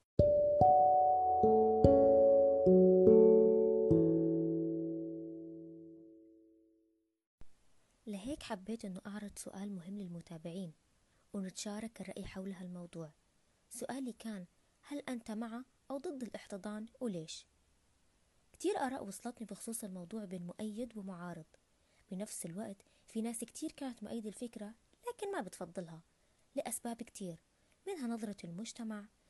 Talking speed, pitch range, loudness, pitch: 90 wpm, 140-225 Hz, -33 LUFS, 190 Hz